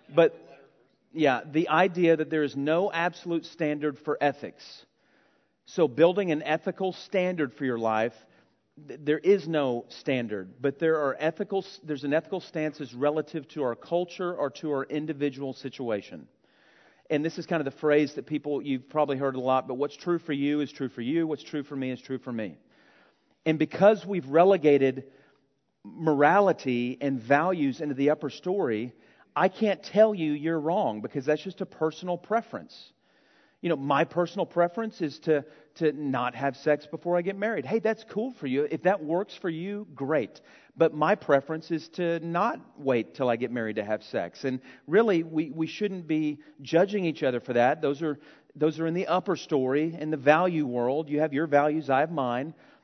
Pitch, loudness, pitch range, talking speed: 155 Hz, -27 LUFS, 140-175 Hz, 190 wpm